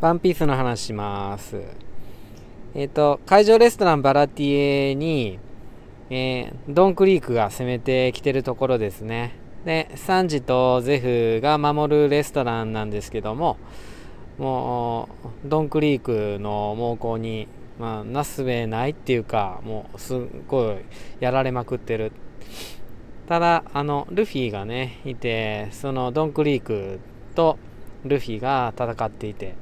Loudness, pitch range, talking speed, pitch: -22 LUFS, 110-145 Hz, 265 characters per minute, 125 Hz